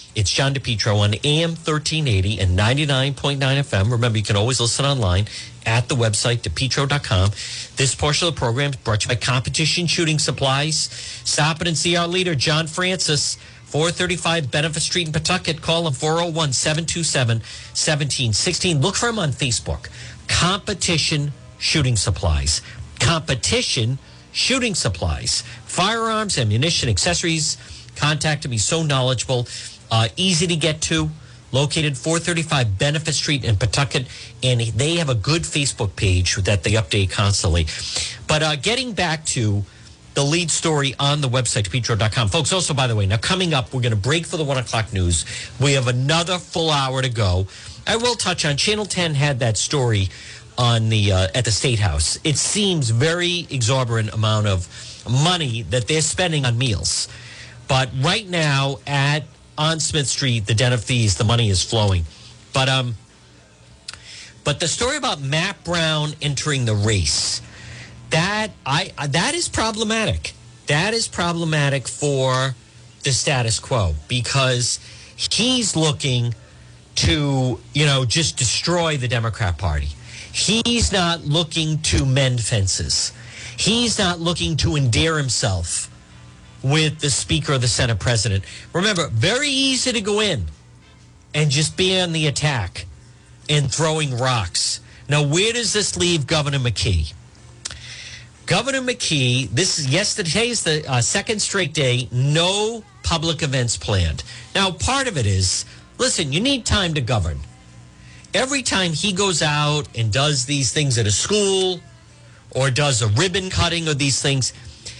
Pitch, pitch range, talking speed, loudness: 135 Hz, 115-165 Hz, 150 wpm, -19 LUFS